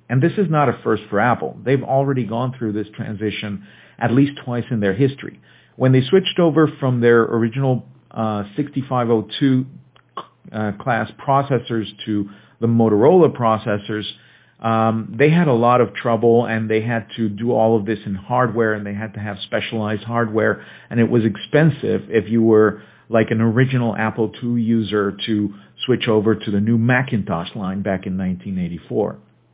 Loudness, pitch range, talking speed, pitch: -19 LUFS, 105-125 Hz, 170 wpm, 115 Hz